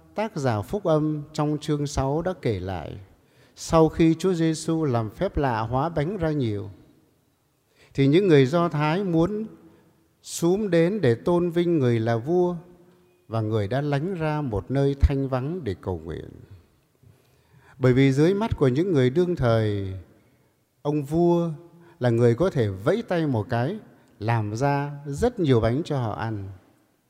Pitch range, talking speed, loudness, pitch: 115-165 Hz, 165 wpm, -24 LUFS, 140 Hz